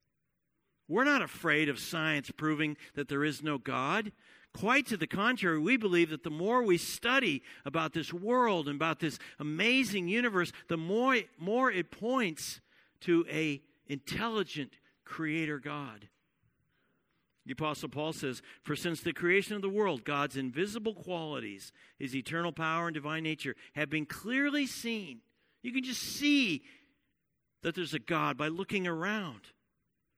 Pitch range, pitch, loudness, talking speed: 150-220 Hz, 170 Hz, -32 LUFS, 150 wpm